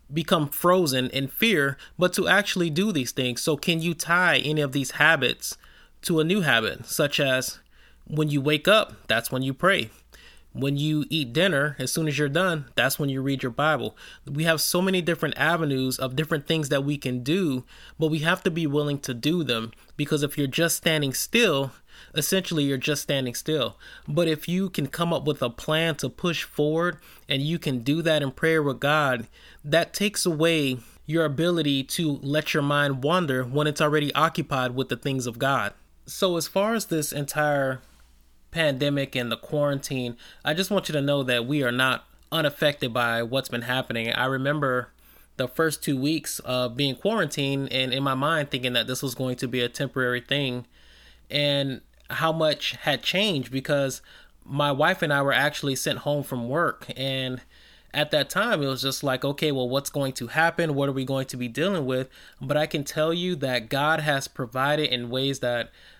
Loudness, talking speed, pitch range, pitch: -25 LUFS, 200 wpm, 130-160 Hz, 145 Hz